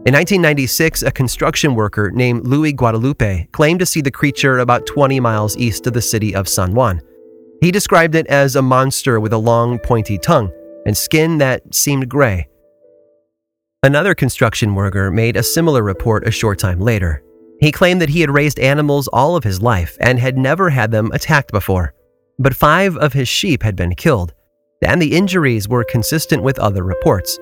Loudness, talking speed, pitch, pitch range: -14 LUFS, 185 wpm, 125 Hz, 105-145 Hz